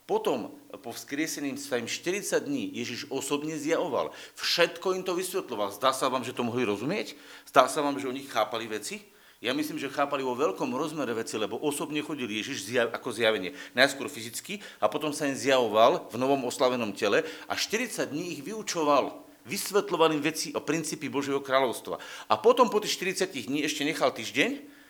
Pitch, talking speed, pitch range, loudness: 150 Hz, 175 wpm, 135-190 Hz, -28 LUFS